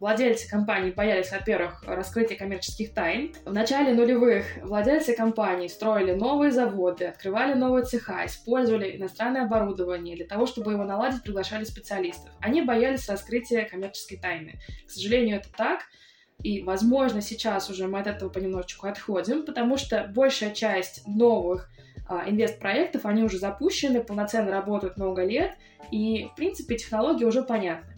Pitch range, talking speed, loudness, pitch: 195-240 Hz, 140 wpm, -26 LUFS, 215 Hz